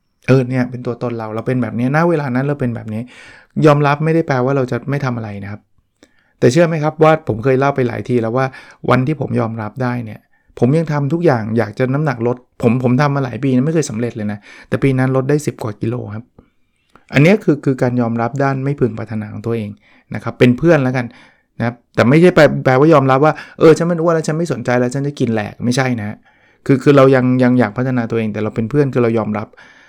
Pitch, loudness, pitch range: 125 Hz, -15 LUFS, 115-140 Hz